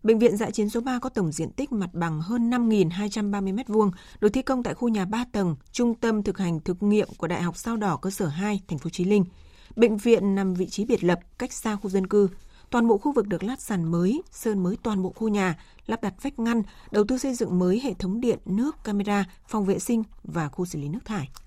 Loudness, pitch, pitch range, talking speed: -26 LUFS, 210 Hz, 185-230 Hz, 250 wpm